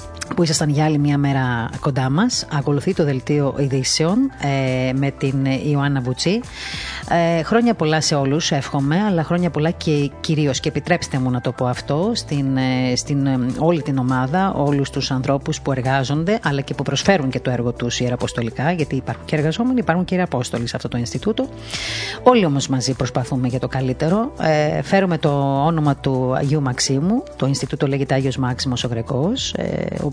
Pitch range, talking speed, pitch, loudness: 130-165 Hz, 175 wpm, 140 Hz, -19 LUFS